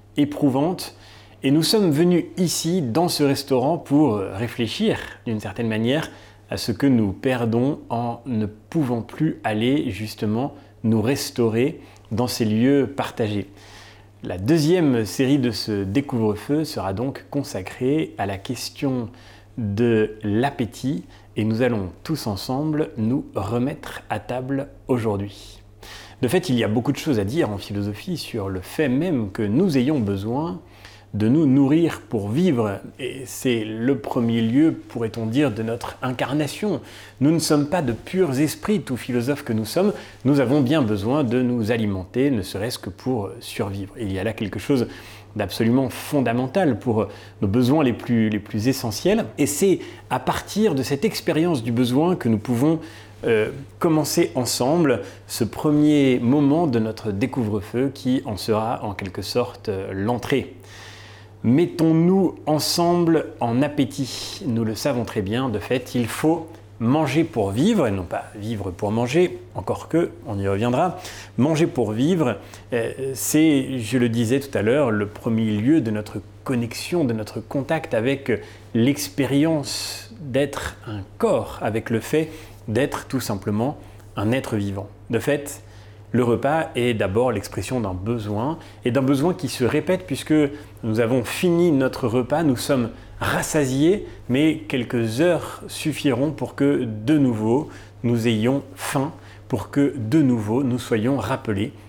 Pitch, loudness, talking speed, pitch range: 120 Hz, -22 LUFS, 155 wpm, 105-140 Hz